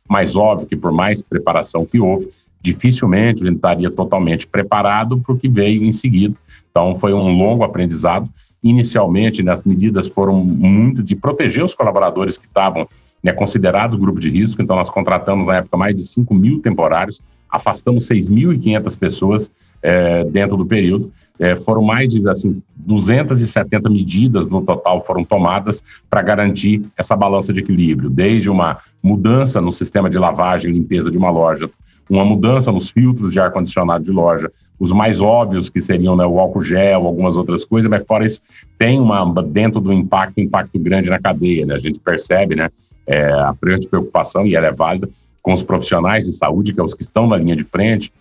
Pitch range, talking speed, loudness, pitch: 90-110 Hz, 185 wpm, -15 LUFS, 100 Hz